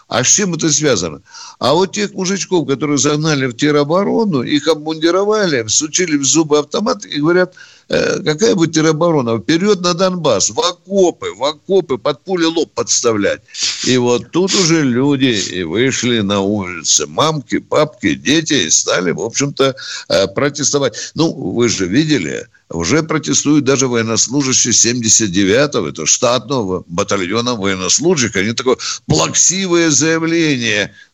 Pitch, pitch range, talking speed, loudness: 150 Hz, 125-170 Hz, 135 wpm, -14 LUFS